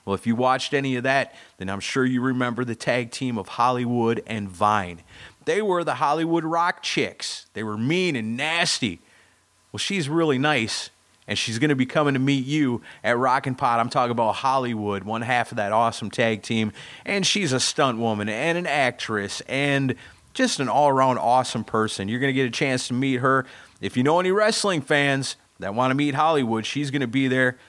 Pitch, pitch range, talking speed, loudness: 130 Hz, 110-145 Hz, 210 wpm, -23 LUFS